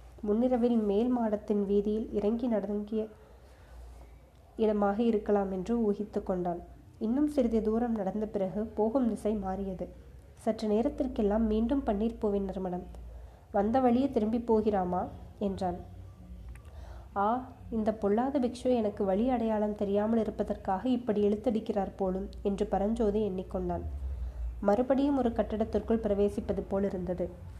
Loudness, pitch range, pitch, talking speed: -31 LUFS, 190-225 Hz, 210 Hz, 110 wpm